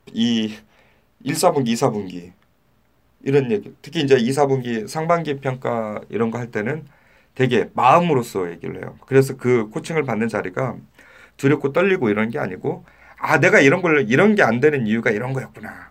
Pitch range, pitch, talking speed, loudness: 110-145 Hz, 125 Hz, 315 characters per minute, -19 LUFS